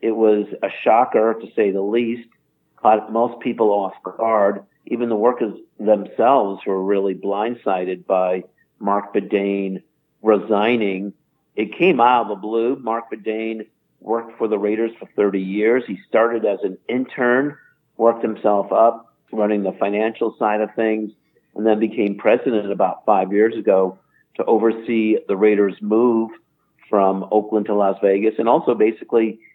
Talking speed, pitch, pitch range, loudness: 150 wpm, 110 Hz, 100-115 Hz, -19 LUFS